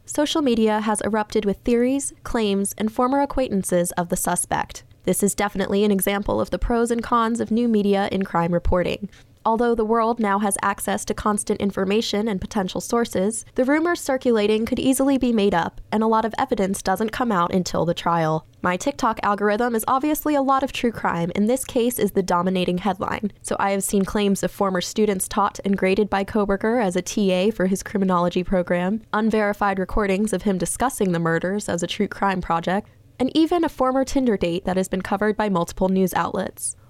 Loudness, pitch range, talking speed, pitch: -22 LUFS, 185-230 Hz, 200 wpm, 205 Hz